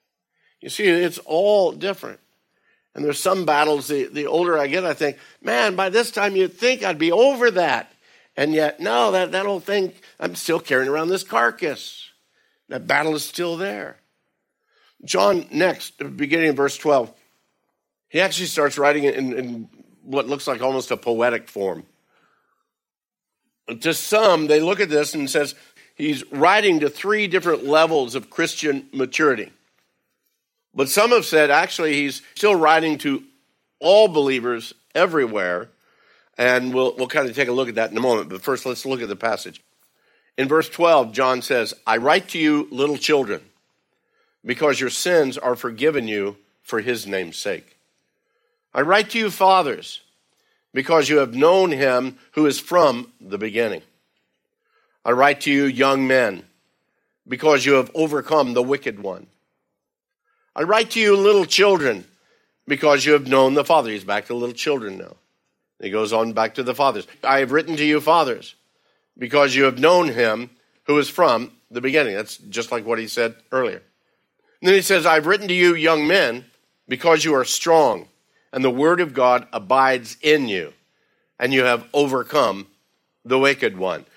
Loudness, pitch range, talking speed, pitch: -19 LUFS, 130-175 Hz, 170 wpm, 145 Hz